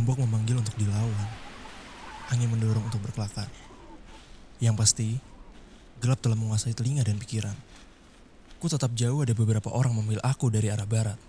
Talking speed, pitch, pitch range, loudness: 145 wpm, 115 Hz, 110-125 Hz, -28 LUFS